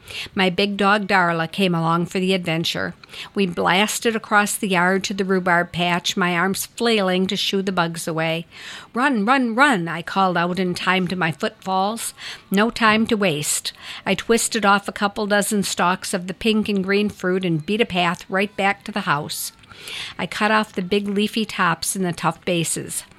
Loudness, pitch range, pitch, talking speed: -20 LUFS, 175-210 Hz, 195 Hz, 190 wpm